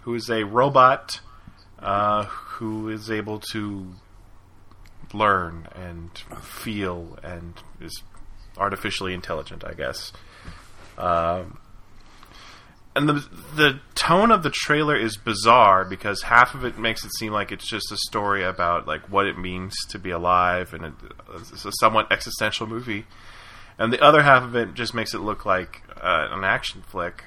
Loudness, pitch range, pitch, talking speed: -22 LUFS, 90-115 Hz, 105 Hz, 150 wpm